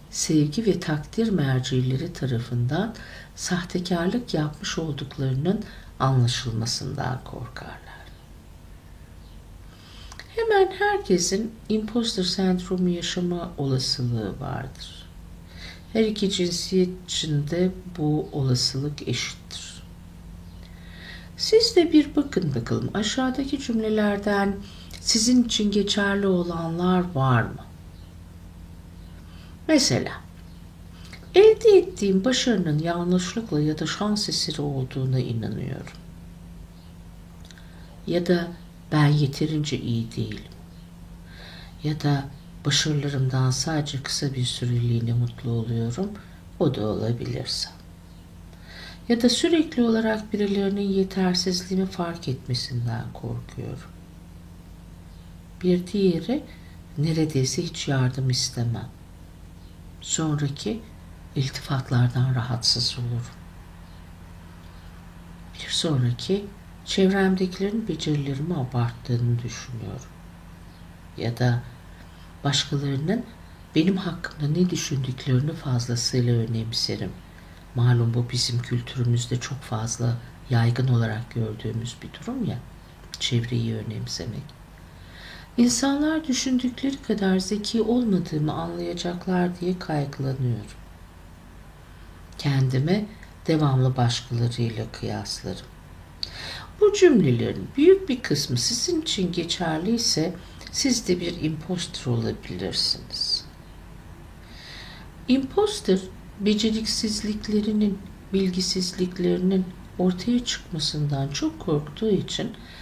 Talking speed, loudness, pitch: 80 wpm, -24 LUFS, 135 Hz